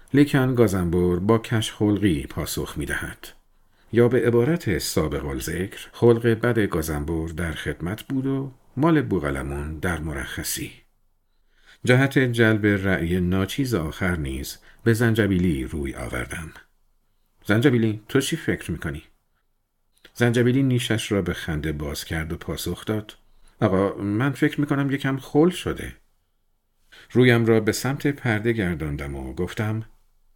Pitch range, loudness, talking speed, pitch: 85-120 Hz, -23 LUFS, 130 wpm, 105 Hz